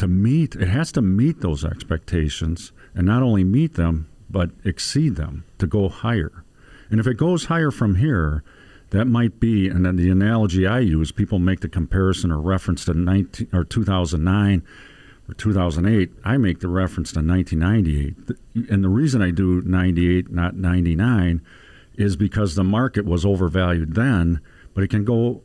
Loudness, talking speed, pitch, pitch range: -20 LUFS, 170 wpm, 95 Hz, 85-110 Hz